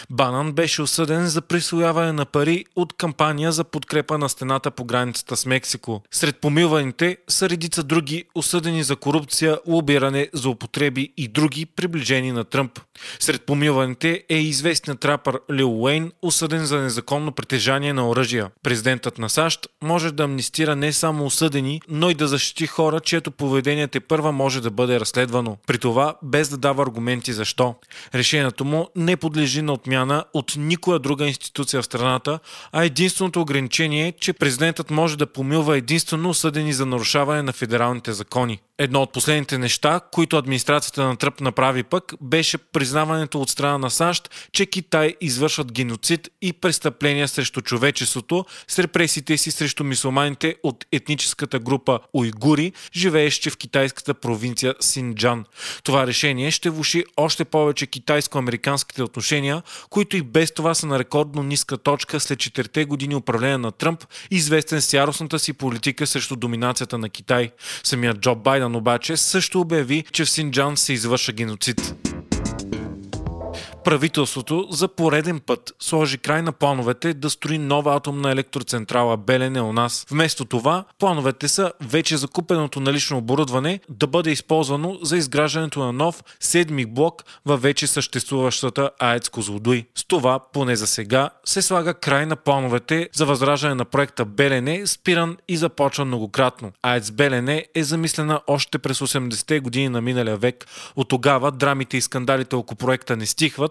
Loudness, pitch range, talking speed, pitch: -21 LUFS, 130-160 Hz, 150 wpm, 145 Hz